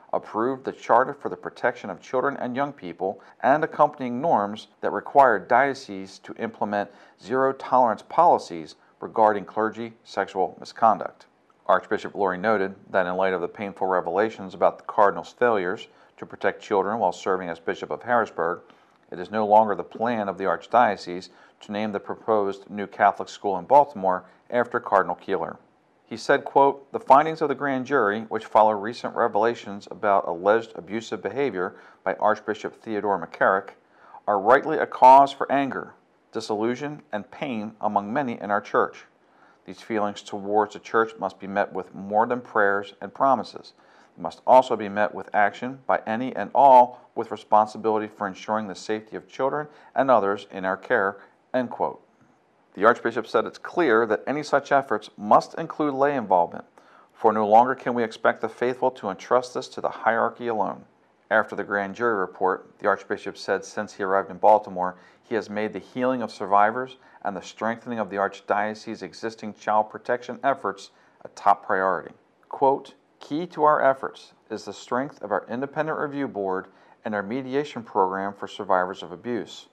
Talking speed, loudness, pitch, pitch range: 170 wpm, -24 LUFS, 110 Hz, 100-125 Hz